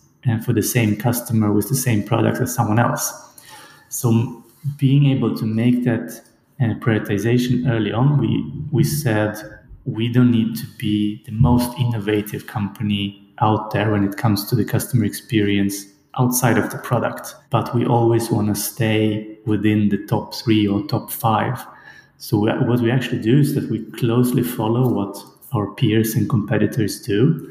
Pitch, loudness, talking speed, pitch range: 115 Hz, -19 LUFS, 165 wpm, 105-125 Hz